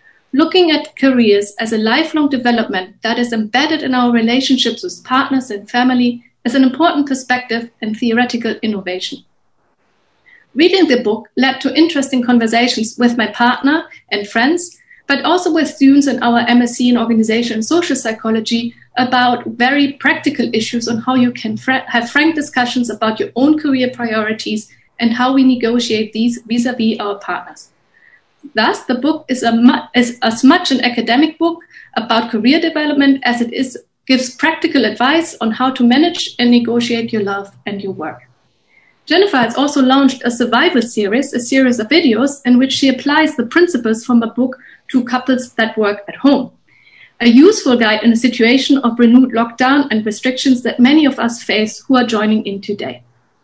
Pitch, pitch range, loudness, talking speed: 245 Hz, 230-275 Hz, -14 LUFS, 170 wpm